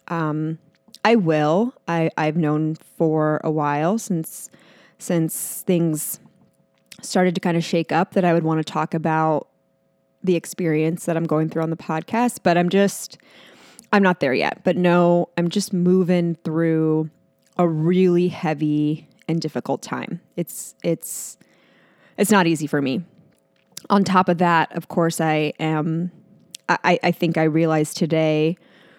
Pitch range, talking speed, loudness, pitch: 160-180 Hz, 155 wpm, -21 LUFS, 170 Hz